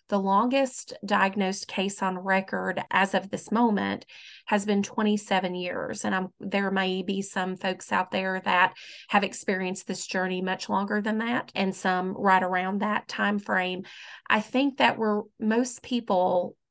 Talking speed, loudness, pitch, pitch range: 160 wpm, -26 LUFS, 195 Hz, 185-210 Hz